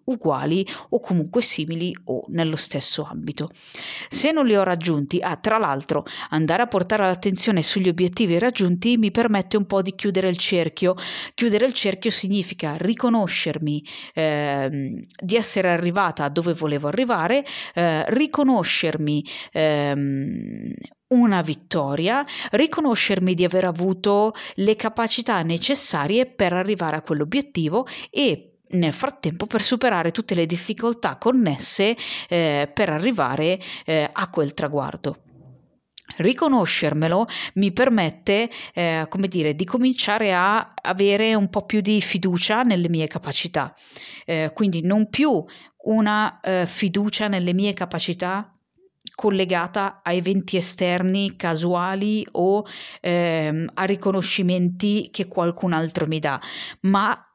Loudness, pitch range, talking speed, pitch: -22 LUFS, 165-215 Hz, 125 wpm, 190 Hz